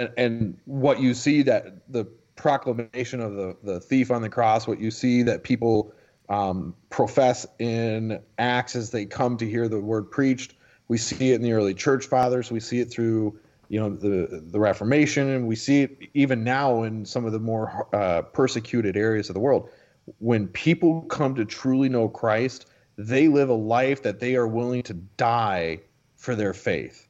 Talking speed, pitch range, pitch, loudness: 190 wpm, 110-130 Hz, 120 Hz, -24 LUFS